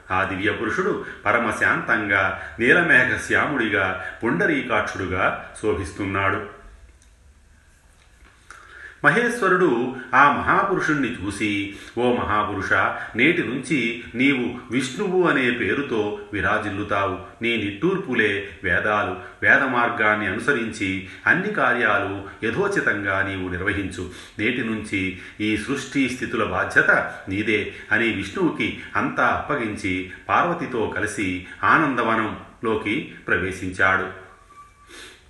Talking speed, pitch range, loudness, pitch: 80 wpm, 95-115 Hz, -21 LUFS, 100 Hz